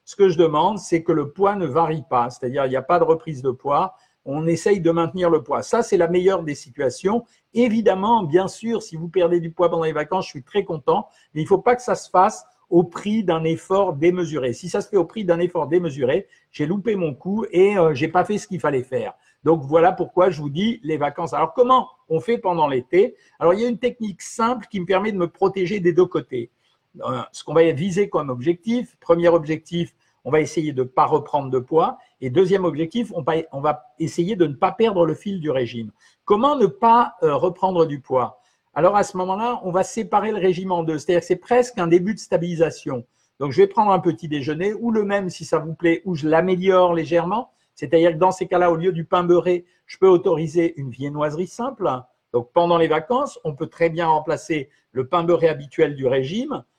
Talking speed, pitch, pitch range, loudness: 230 wpm, 175 Hz, 160-195 Hz, -20 LUFS